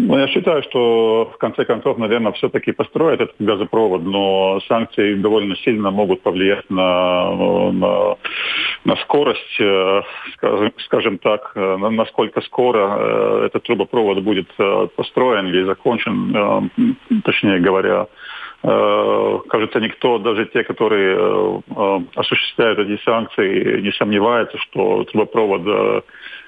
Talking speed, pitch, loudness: 100 wpm, 115 Hz, -17 LUFS